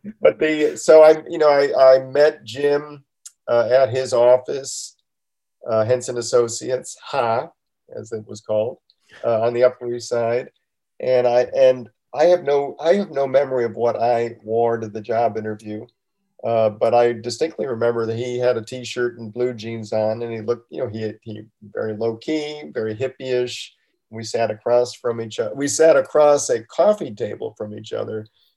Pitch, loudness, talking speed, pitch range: 120 Hz, -19 LUFS, 185 wpm, 115-140 Hz